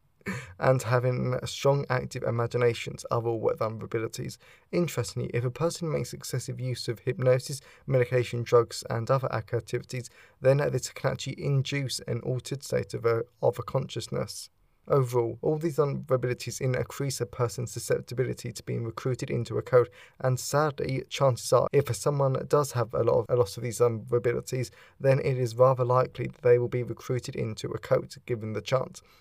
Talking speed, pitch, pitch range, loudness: 170 wpm, 125 Hz, 120-135 Hz, -28 LUFS